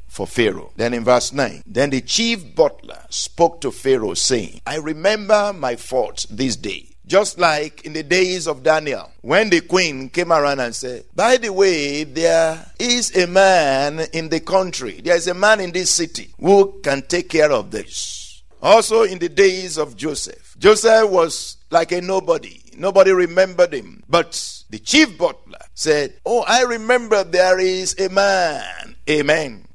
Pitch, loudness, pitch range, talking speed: 180 Hz, -17 LUFS, 155-200 Hz, 170 wpm